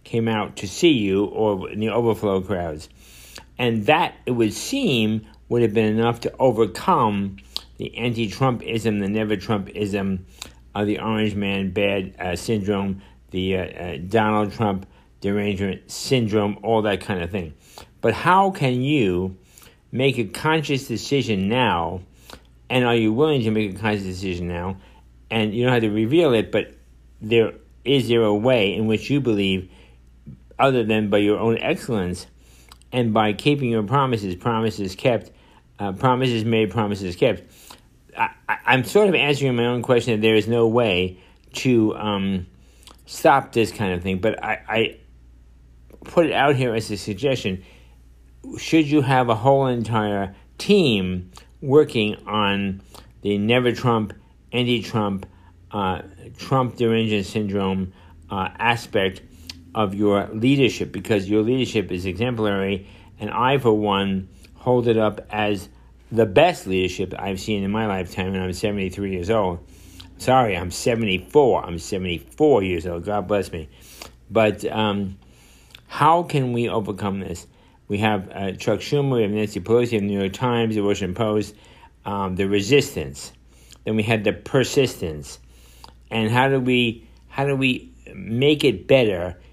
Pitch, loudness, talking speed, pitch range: 105 Hz, -21 LUFS, 155 wpm, 95-115 Hz